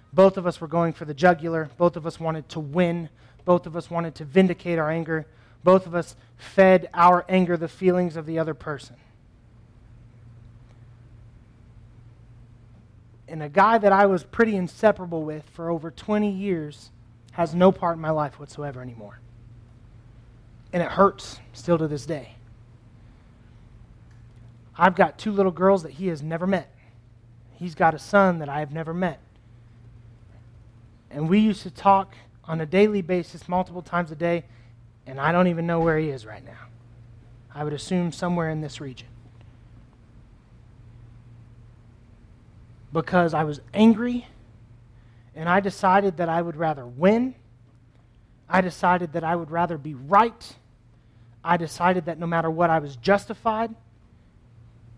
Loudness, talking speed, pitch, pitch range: -23 LUFS, 155 wpm, 150 Hz, 115-175 Hz